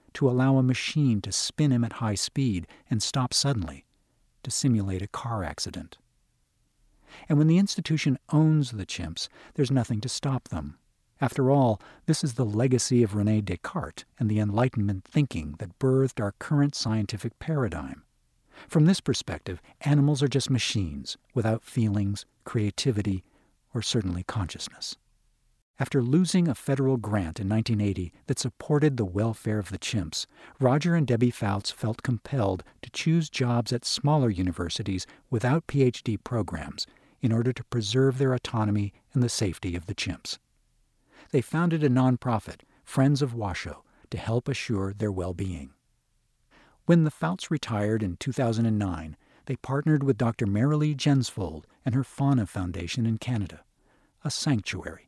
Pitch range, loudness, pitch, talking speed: 100-135 Hz, -27 LUFS, 120 Hz, 145 wpm